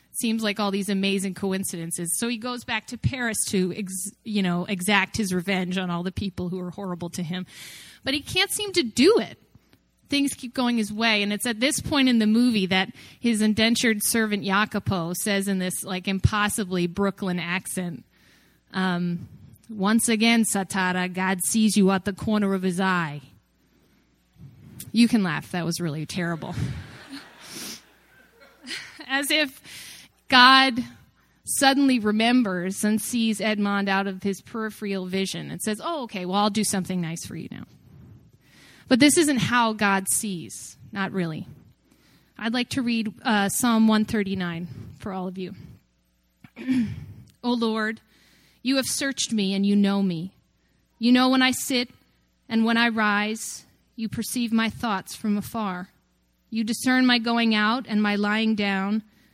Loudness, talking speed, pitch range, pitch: -23 LUFS, 160 wpm, 185-230 Hz, 205 Hz